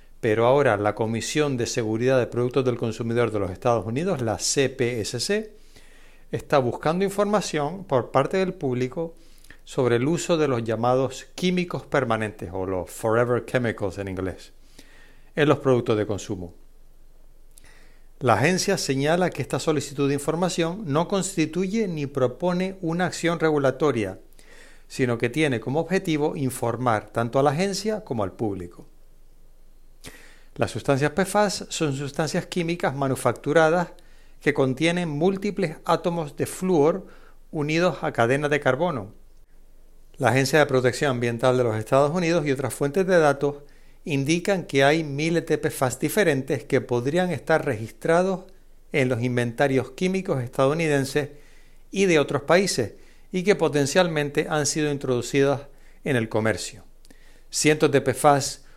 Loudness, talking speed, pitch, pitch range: -23 LUFS, 135 wpm, 145 Hz, 125-165 Hz